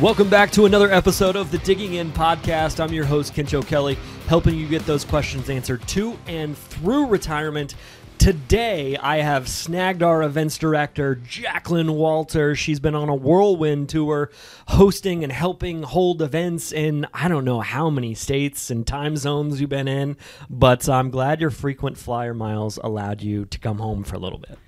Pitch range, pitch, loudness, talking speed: 135-165 Hz, 150 Hz, -21 LUFS, 180 wpm